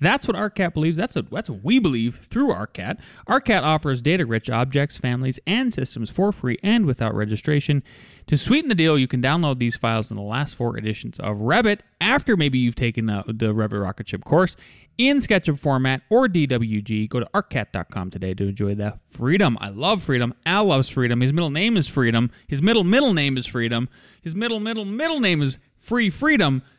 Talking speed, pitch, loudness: 195 wpm, 140 Hz, -21 LUFS